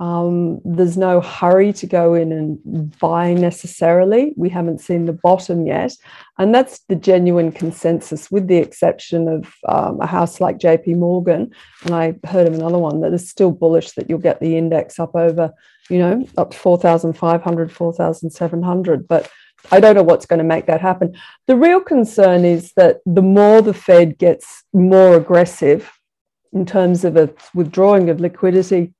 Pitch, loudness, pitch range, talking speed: 175 Hz, -15 LUFS, 165-185 Hz, 170 wpm